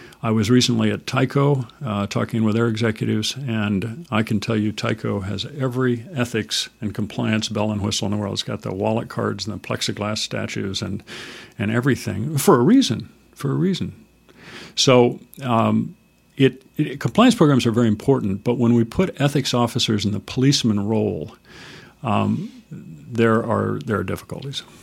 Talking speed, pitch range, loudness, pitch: 170 wpm, 105-130 Hz, -21 LUFS, 115 Hz